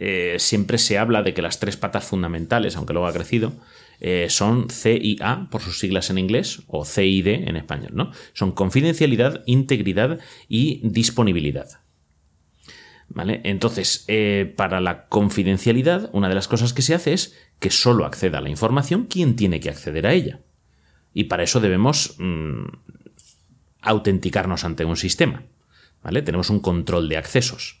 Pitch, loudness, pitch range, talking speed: 100 Hz, -21 LUFS, 90-120 Hz, 165 wpm